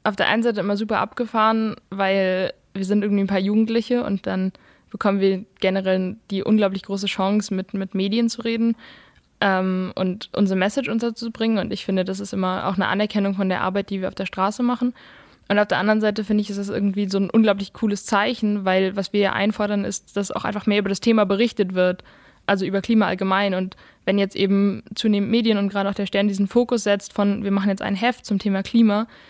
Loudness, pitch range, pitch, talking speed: -22 LUFS, 195-215 Hz, 200 Hz, 220 wpm